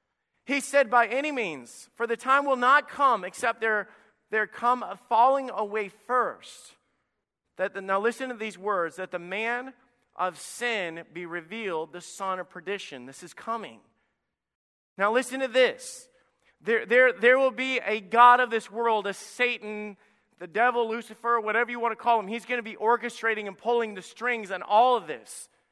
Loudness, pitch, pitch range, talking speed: -26 LUFS, 230 Hz, 205-245 Hz, 180 wpm